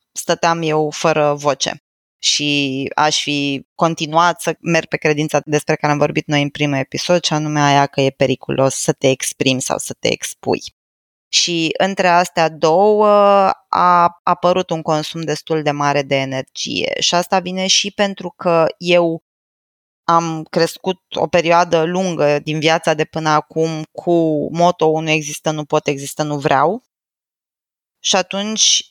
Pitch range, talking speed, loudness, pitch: 145-175 Hz, 155 wpm, -16 LUFS, 160 Hz